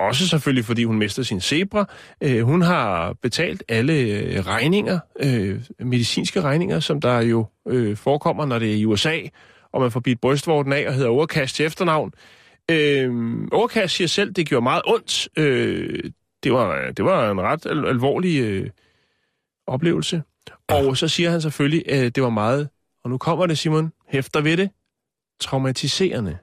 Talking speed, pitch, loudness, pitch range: 165 wpm, 135 Hz, -21 LUFS, 120-160 Hz